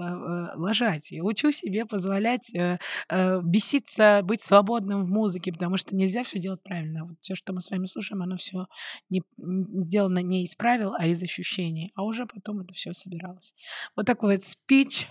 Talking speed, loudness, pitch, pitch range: 170 wpm, -26 LUFS, 190 Hz, 180-210 Hz